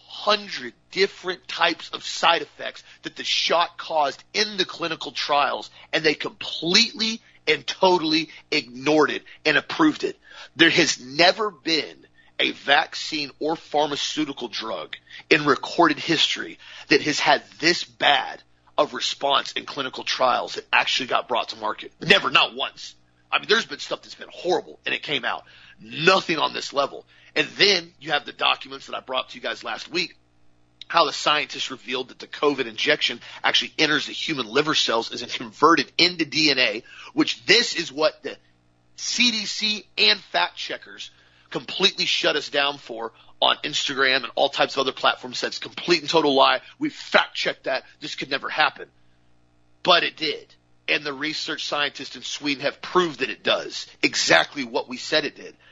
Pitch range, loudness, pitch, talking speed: 125-195 Hz, -22 LUFS, 155 Hz, 170 wpm